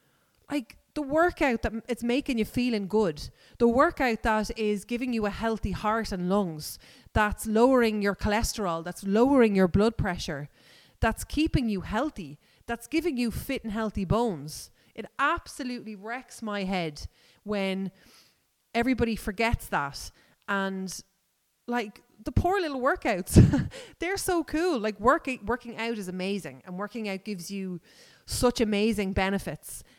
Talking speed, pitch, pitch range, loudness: 145 wpm, 220 Hz, 195-245 Hz, -28 LUFS